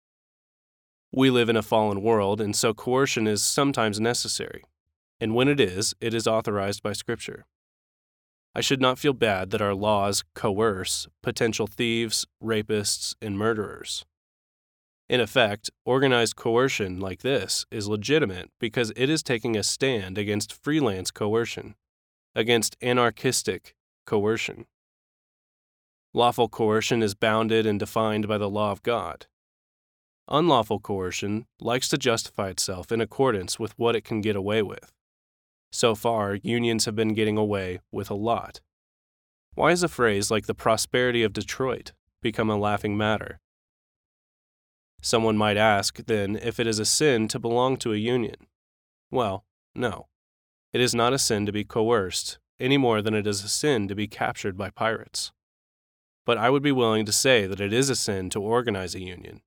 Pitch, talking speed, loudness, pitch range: 110 Hz, 155 wpm, -25 LUFS, 100-115 Hz